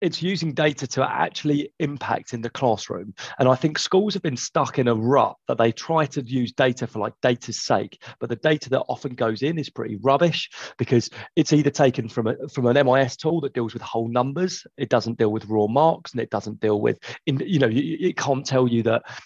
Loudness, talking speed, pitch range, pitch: -23 LUFS, 225 wpm, 120-150 Hz, 130 Hz